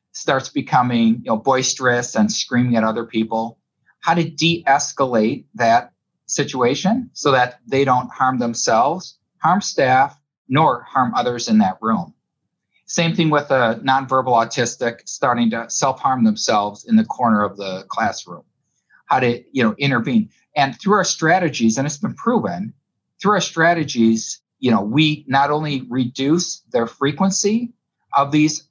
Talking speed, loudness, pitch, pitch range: 150 wpm, -18 LUFS, 135 Hz, 120-170 Hz